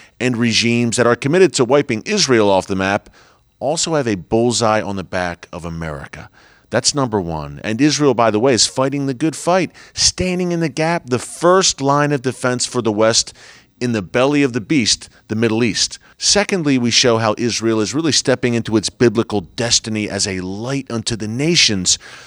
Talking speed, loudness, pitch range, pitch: 195 wpm, -16 LUFS, 105-140 Hz, 120 Hz